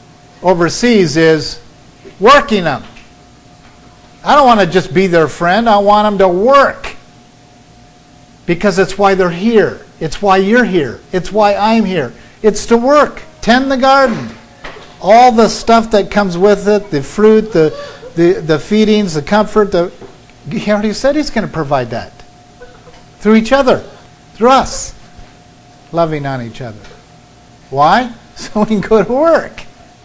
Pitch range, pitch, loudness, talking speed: 170-220 Hz, 205 Hz, -11 LUFS, 150 wpm